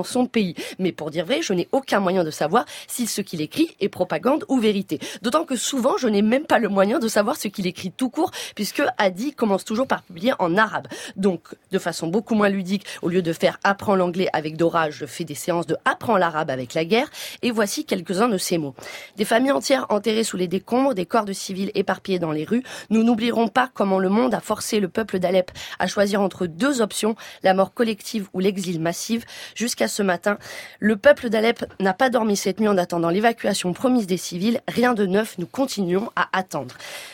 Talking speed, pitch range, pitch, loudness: 220 wpm, 180-235 Hz, 205 Hz, -22 LUFS